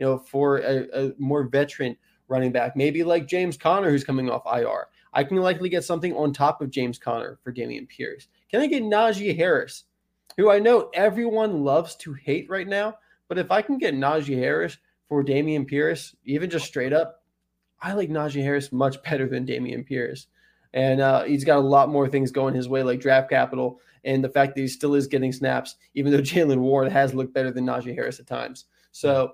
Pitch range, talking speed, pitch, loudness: 130-165 Hz, 210 wpm, 140 Hz, -23 LUFS